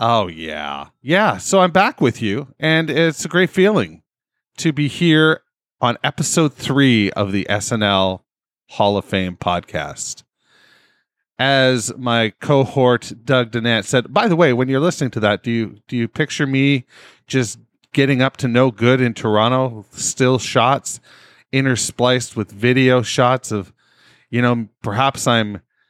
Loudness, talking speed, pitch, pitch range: -17 LUFS, 150 wpm, 125 Hz, 110-140 Hz